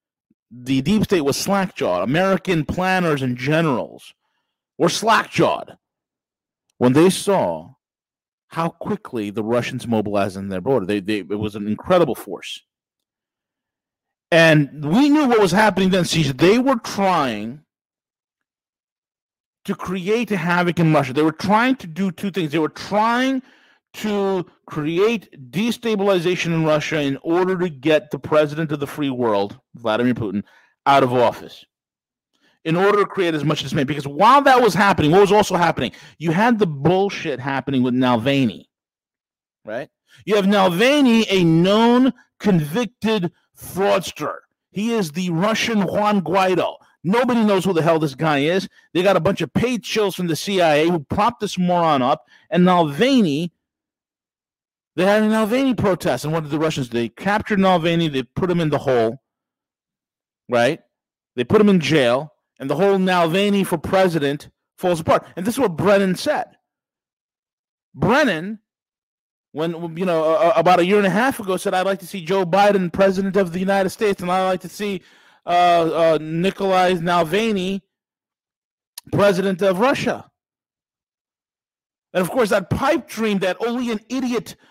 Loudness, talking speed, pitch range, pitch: -19 LUFS, 160 wpm, 155-205 Hz, 180 Hz